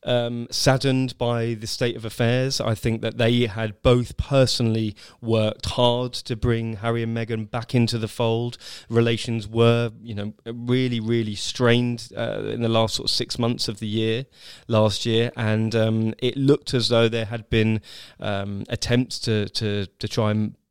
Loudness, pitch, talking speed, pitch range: -23 LUFS, 115 Hz, 175 wpm, 110-120 Hz